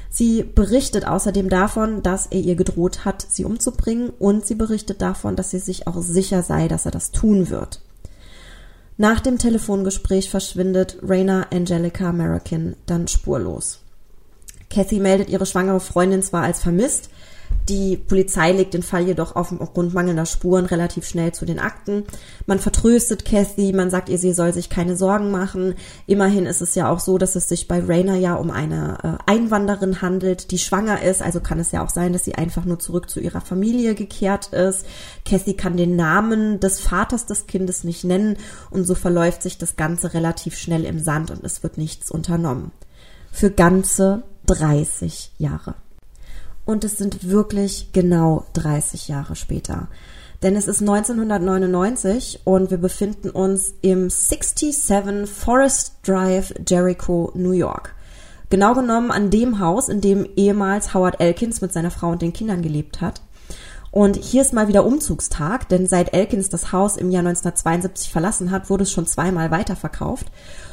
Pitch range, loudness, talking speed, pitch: 175-200 Hz, -19 LUFS, 165 wpm, 185 Hz